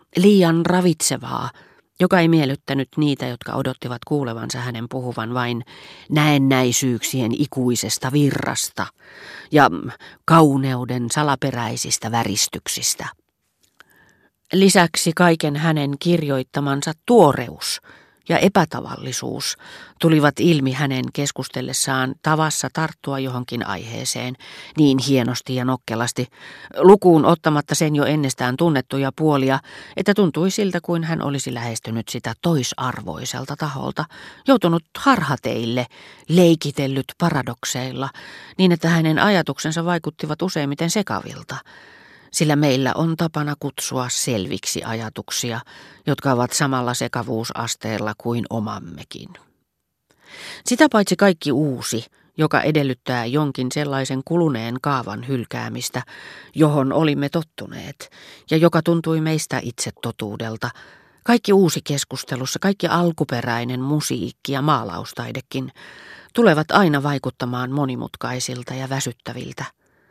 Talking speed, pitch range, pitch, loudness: 95 wpm, 125-160 Hz, 140 Hz, -20 LUFS